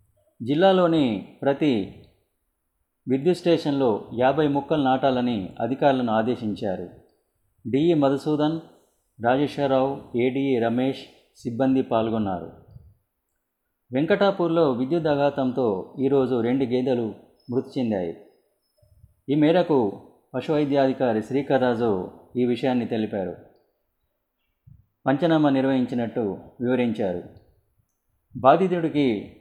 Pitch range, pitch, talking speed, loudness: 115-145 Hz, 130 Hz, 70 wpm, -23 LUFS